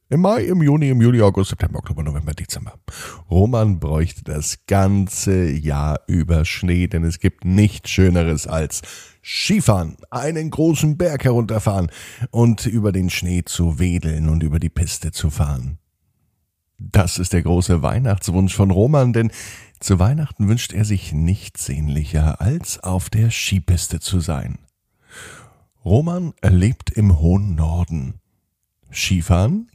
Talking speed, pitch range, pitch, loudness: 135 wpm, 85-110 Hz, 95 Hz, -19 LUFS